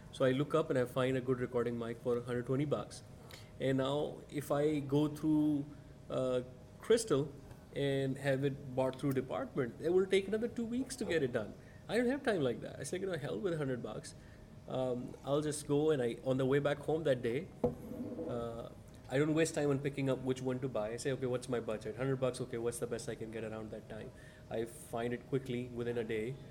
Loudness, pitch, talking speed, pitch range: -36 LUFS, 130 Hz, 230 wpm, 120-145 Hz